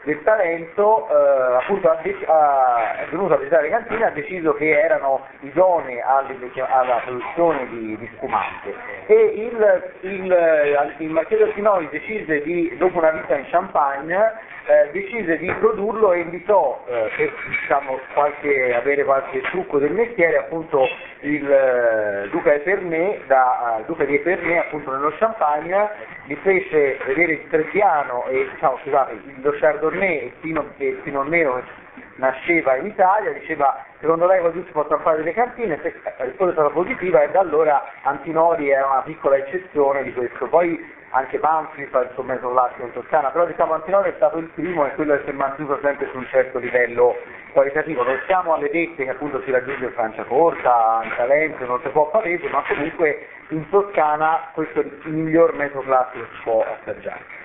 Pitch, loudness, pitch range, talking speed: 155 Hz, -20 LUFS, 135-185 Hz, 175 wpm